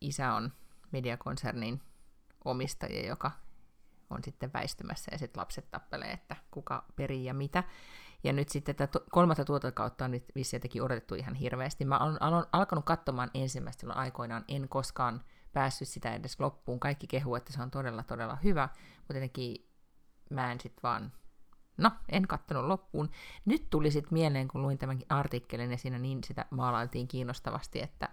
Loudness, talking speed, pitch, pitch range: -35 LUFS, 160 wpm, 135 Hz, 125-145 Hz